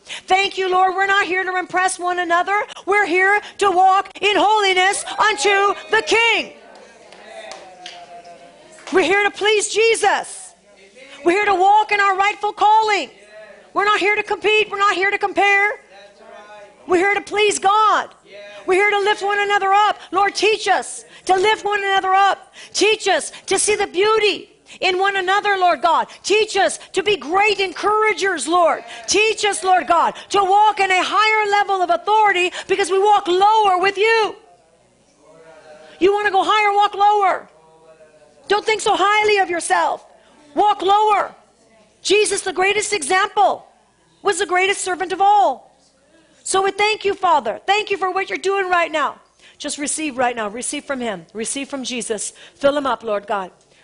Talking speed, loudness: 170 wpm, -17 LUFS